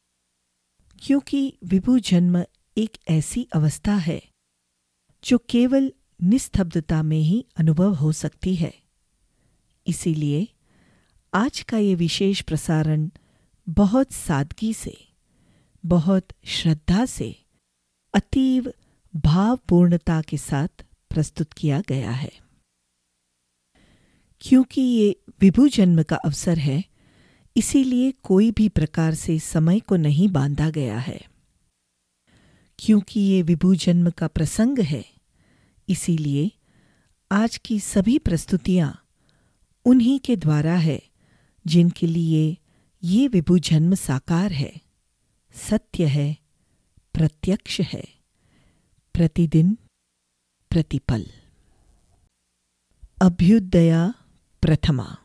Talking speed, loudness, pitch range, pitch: 90 wpm, -21 LUFS, 145-200 Hz, 170 Hz